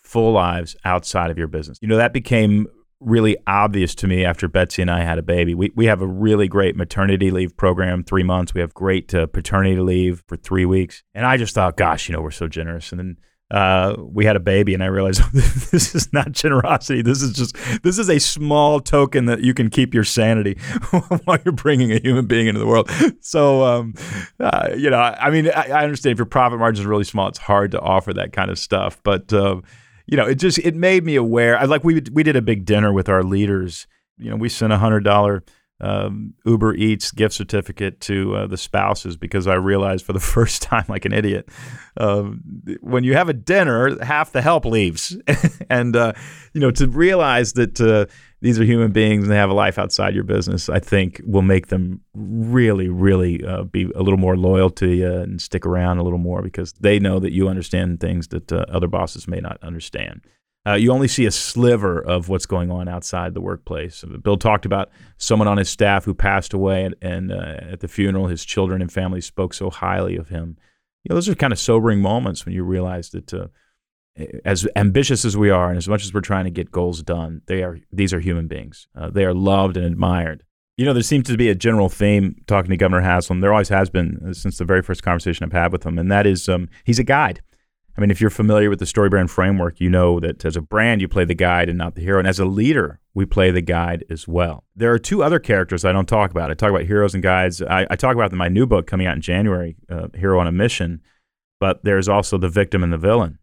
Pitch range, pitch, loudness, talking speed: 90-115 Hz, 100 Hz, -18 LUFS, 240 wpm